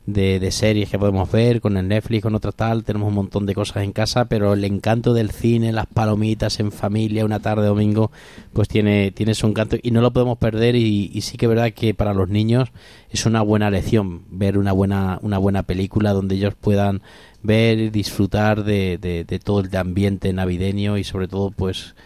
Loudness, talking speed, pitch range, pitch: -20 LUFS, 210 wpm, 100-110 Hz, 105 Hz